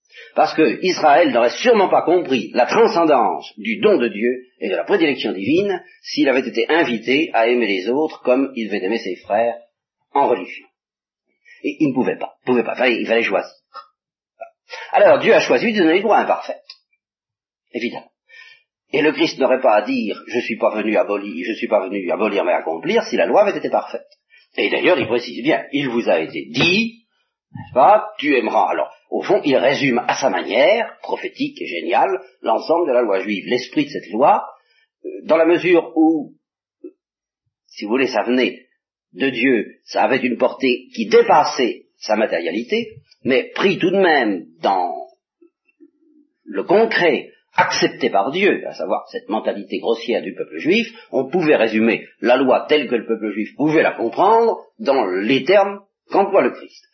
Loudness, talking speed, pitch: -18 LUFS, 180 wpm, 230 Hz